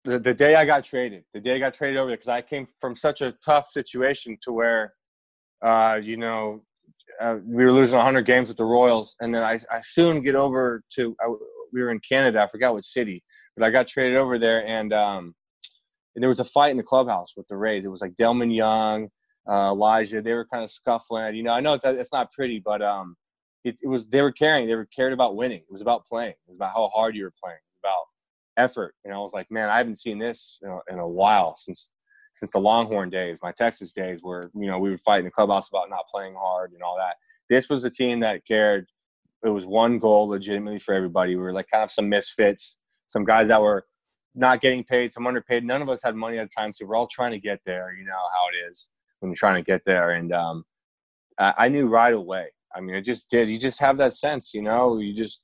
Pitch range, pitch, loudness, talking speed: 105-125 Hz, 115 Hz, -23 LUFS, 250 wpm